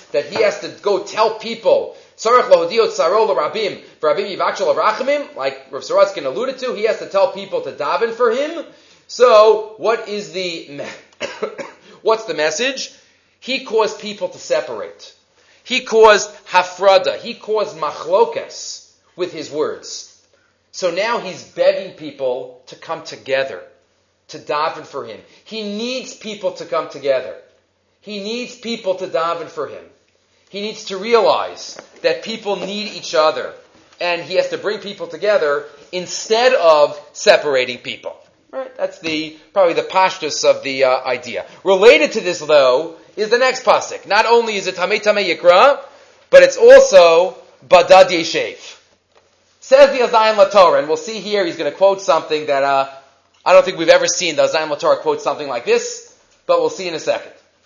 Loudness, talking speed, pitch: -16 LUFS, 160 wpm, 225 Hz